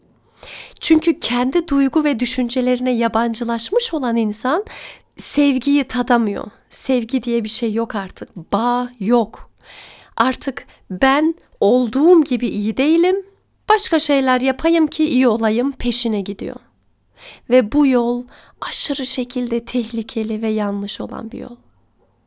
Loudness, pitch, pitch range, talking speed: -17 LUFS, 245 Hz, 230-280 Hz, 115 wpm